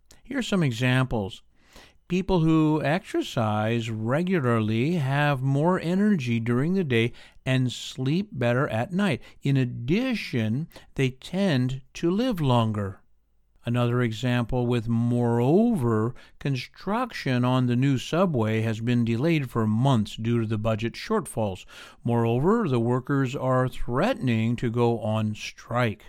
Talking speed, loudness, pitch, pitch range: 125 wpm, -25 LUFS, 125 Hz, 115-155 Hz